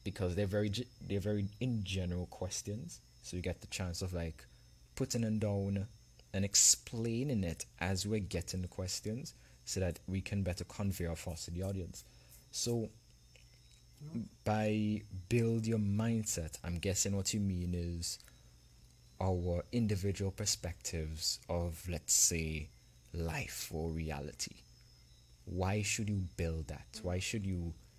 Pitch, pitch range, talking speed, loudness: 90 Hz, 80-105 Hz, 140 wpm, -37 LUFS